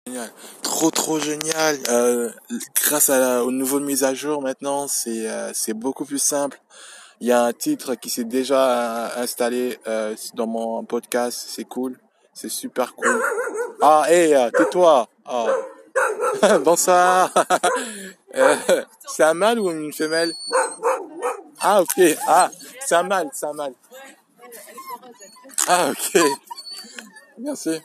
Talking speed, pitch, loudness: 135 wpm, 160 Hz, -20 LUFS